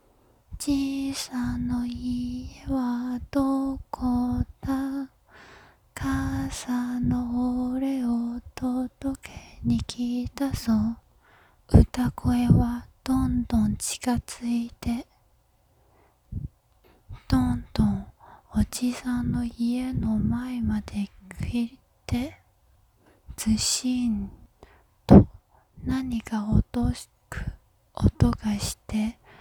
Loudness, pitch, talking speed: -26 LUFS, 240 Hz, 135 characters per minute